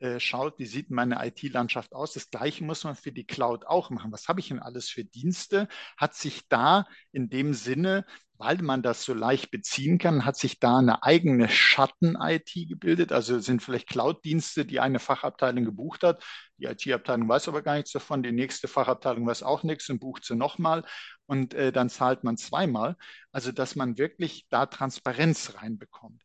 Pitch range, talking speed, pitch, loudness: 125-155 Hz, 185 wpm, 135 Hz, -27 LUFS